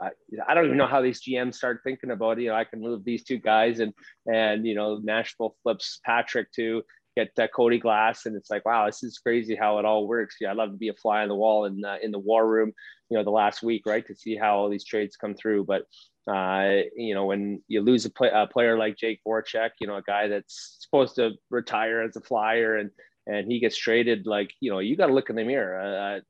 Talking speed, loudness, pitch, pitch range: 260 wpm, -26 LUFS, 110 Hz, 105-115 Hz